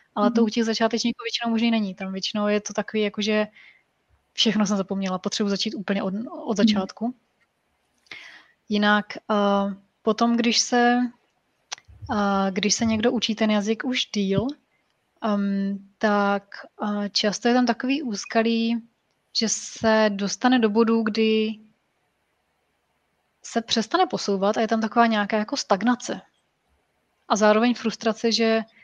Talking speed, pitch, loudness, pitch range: 130 wpm, 220 Hz, -23 LUFS, 205-230 Hz